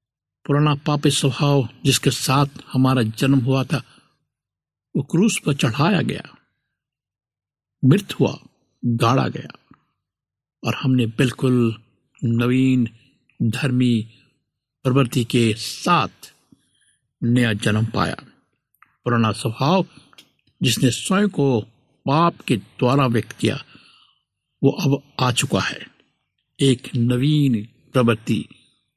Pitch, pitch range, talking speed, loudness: 130 Hz, 120-140 Hz, 95 wpm, -20 LUFS